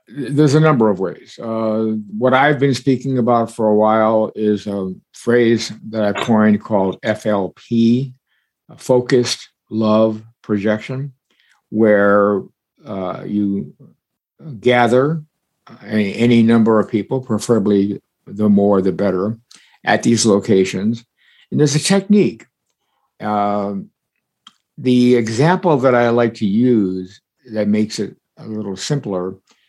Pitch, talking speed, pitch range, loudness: 110 Hz, 120 wpm, 105-125 Hz, -16 LUFS